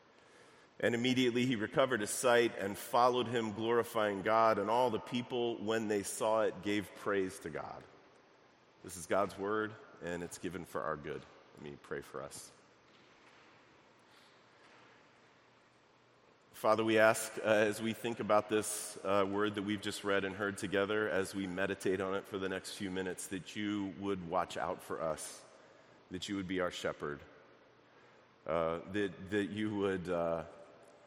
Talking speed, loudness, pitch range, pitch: 165 wpm, -35 LUFS, 95-110 Hz, 105 Hz